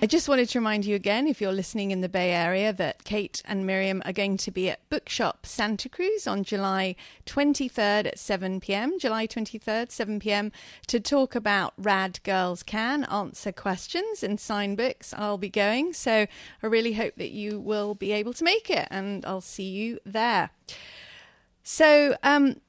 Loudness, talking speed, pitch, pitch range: -26 LUFS, 185 wpm, 210 Hz, 195-240 Hz